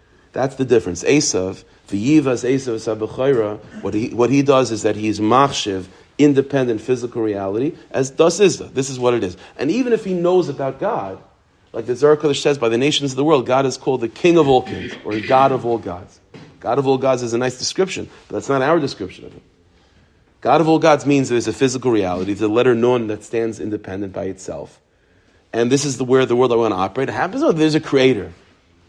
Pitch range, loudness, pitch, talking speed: 105-140 Hz, -18 LUFS, 125 Hz, 220 wpm